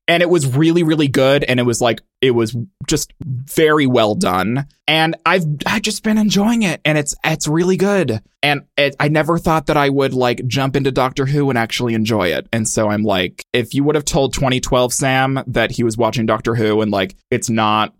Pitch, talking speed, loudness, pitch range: 135 Hz, 220 wpm, -16 LUFS, 115-155 Hz